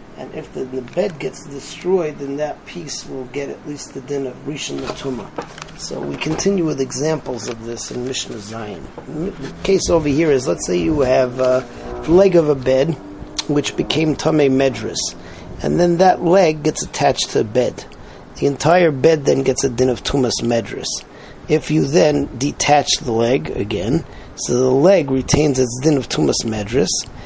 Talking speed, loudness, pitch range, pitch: 180 wpm, -18 LUFS, 130-155 Hz, 140 Hz